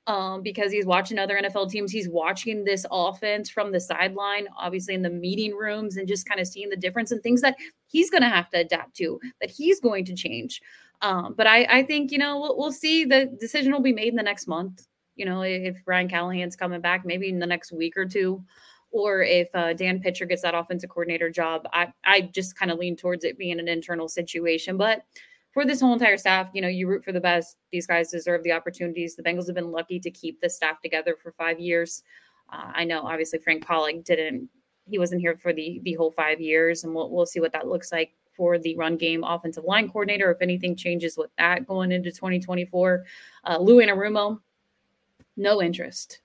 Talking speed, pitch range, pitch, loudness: 220 wpm, 170-205 Hz, 180 Hz, -24 LUFS